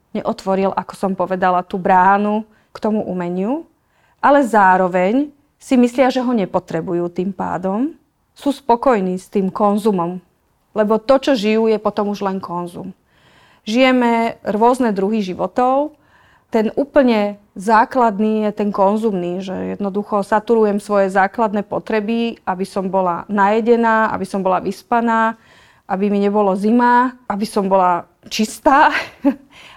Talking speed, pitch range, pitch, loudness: 130 wpm, 190-235 Hz, 210 Hz, -17 LUFS